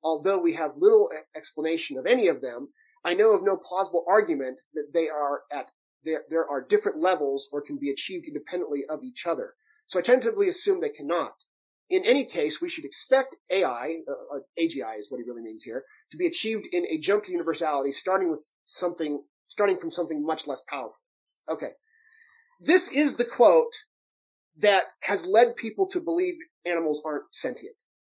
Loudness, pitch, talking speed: -25 LUFS, 190 Hz, 175 wpm